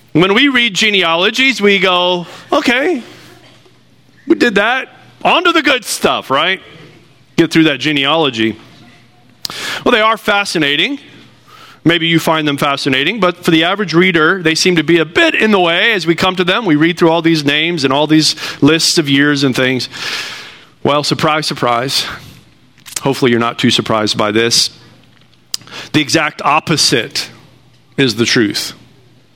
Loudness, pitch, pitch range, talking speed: -12 LUFS, 155 Hz, 135-180 Hz, 160 wpm